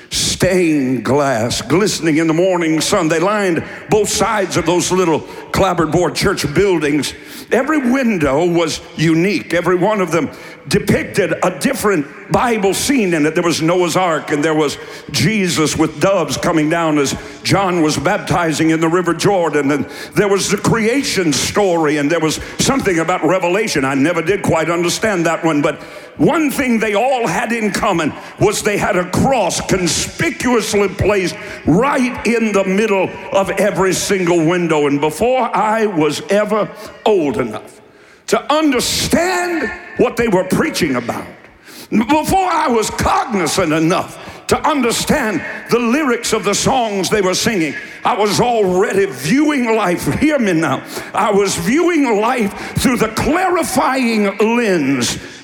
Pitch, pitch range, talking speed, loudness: 195 Hz, 165-225 Hz, 150 wpm, -15 LUFS